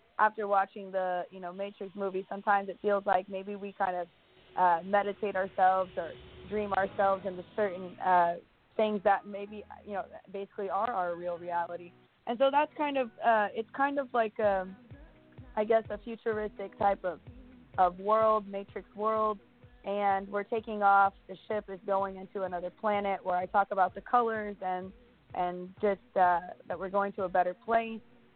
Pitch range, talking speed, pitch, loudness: 185-215 Hz, 175 wpm, 200 Hz, -31 LUFS